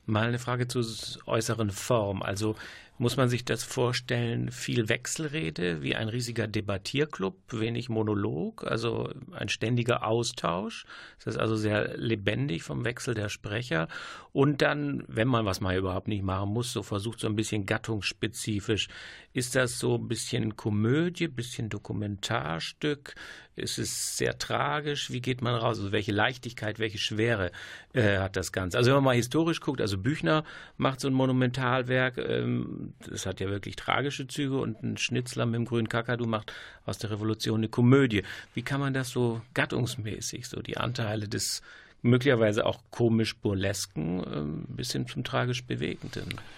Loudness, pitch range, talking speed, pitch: -29 LUFS, 105-125 Hz, 160 wpm, 115 Hz